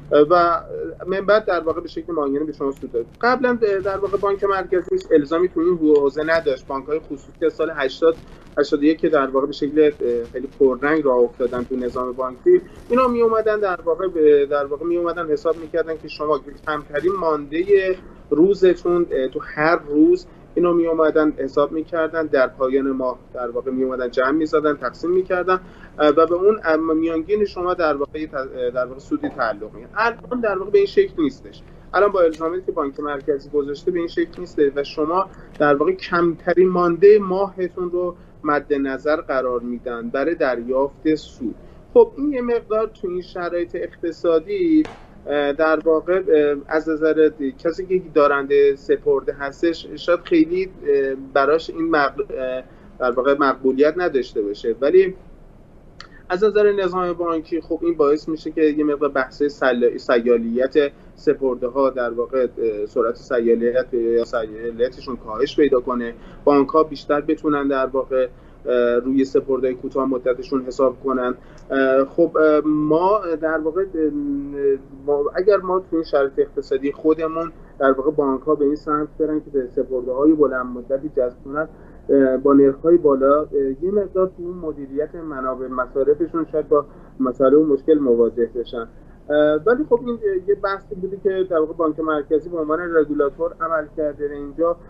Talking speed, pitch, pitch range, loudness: 155 wpm, 155 Hz, 140-185 Hz, -20 LUFS